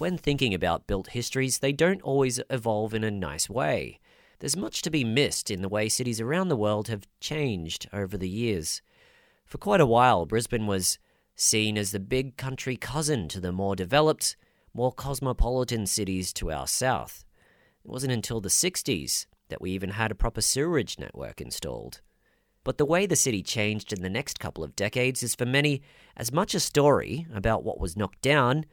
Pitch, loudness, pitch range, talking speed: 115 Hz, -27 LUFS, 100-135 Hz, 190 wpm